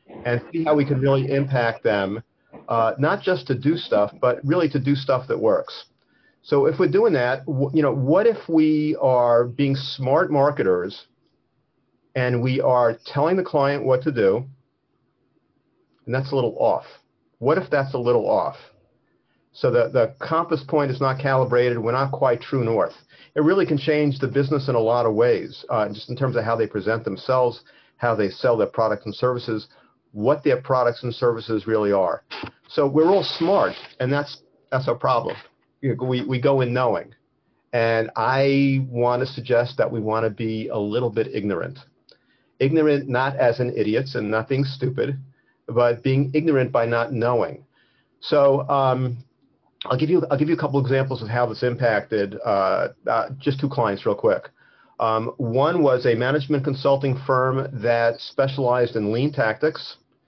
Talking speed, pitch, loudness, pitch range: 180 wpm, 135 Hz, -21 LUFS, 120-145 Hz